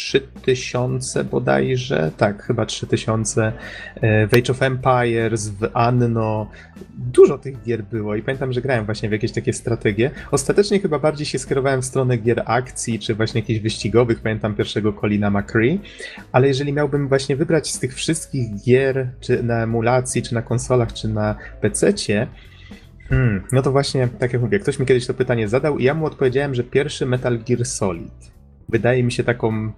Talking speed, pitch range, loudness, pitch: 170 wpm, 110-130 Hz, -20 LUFS, 120 Hz